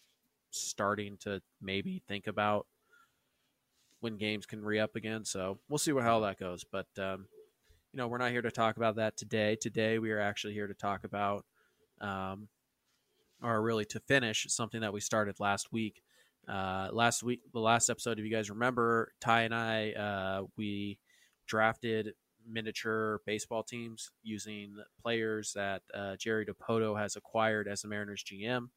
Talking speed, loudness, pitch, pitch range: 165 wpm, -35 LUFS, 110 Hz, 100-115 Hz